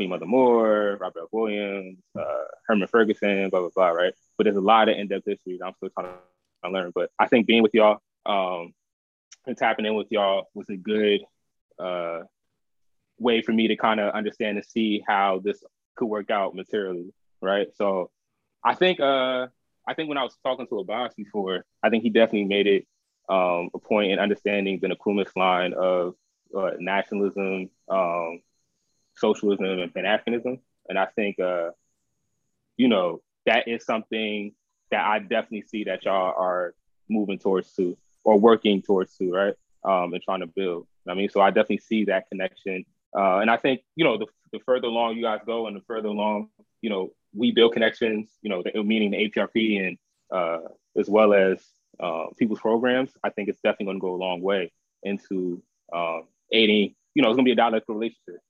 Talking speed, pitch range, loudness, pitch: 195 wpm, 95-110 Hz, -24 LUFS, 100 Hz